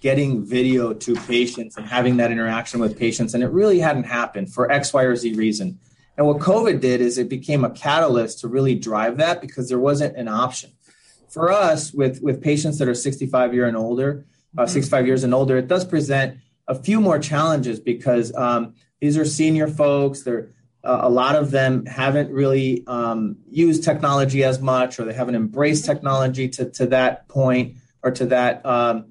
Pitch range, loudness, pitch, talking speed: 120-140 Hz, -20 LUFS, 130 Hz, 195 wpm